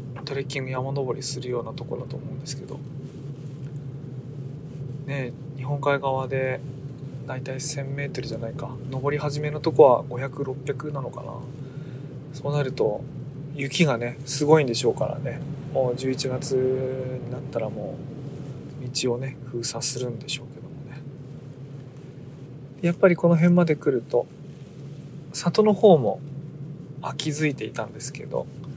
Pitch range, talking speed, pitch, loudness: 130-145 Hz, 265 characters per minute, 140 Hz, -25 LUFS